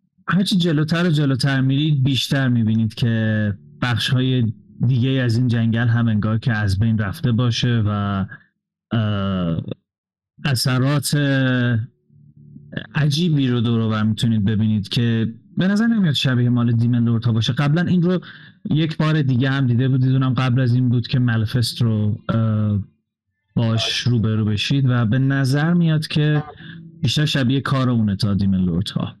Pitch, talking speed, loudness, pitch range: 125 Hz, 140 wpm, -19 LUFS, 110-140 Hz